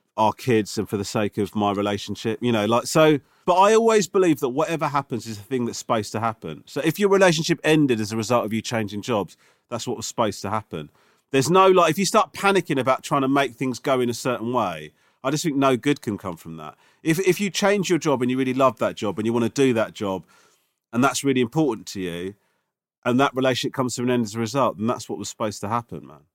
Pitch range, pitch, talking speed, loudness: 110-150 Hz, 125 Hz, 260 wpm, -22 LUFS